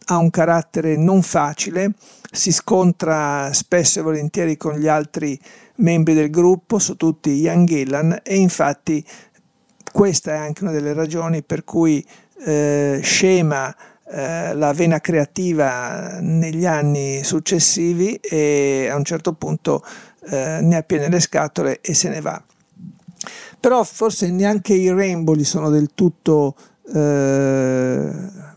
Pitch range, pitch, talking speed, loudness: 150-185 Hz, 165 Hz, 130 wpm, -18 LUFS